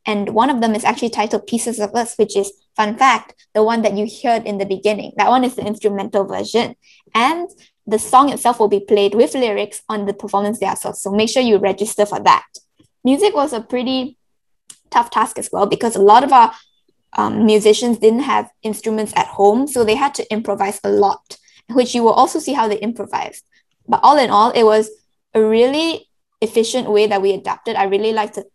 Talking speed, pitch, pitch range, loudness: 210 wpm, 220 Hz, 210-240 Hz, -16 LUFS